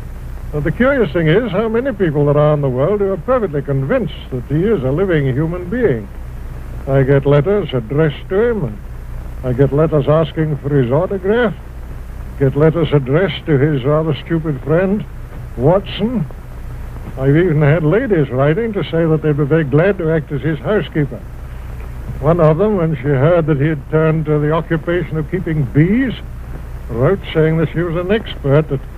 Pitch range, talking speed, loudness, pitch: 135-165 Hz, 180 wpm, -15 LUFS, 150 Hz